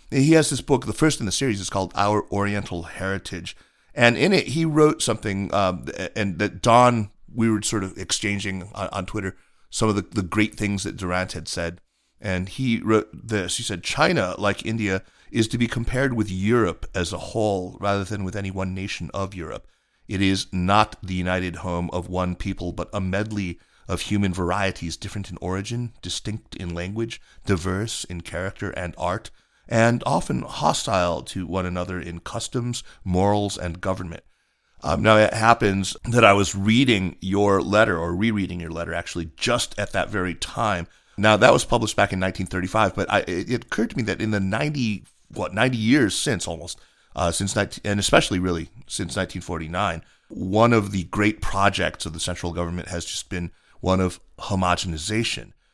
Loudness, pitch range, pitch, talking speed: -23 LUFS, 90-110 Hz, 100 Hz, 185 wpm